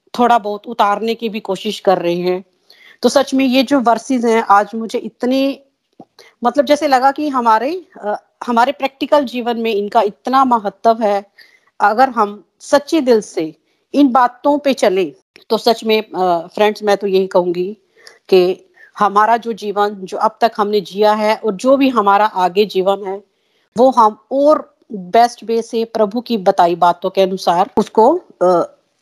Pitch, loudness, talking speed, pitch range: 225 Hz, -15 LUFS, 170 wpm, 205-265 Hz